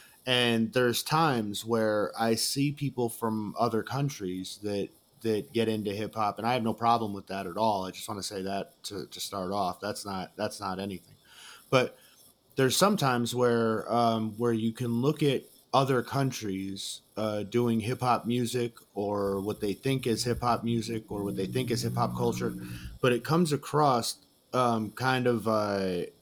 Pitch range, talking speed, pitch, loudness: 100-125 Hz, 185 wpm, 115 Hz, -29 LUFS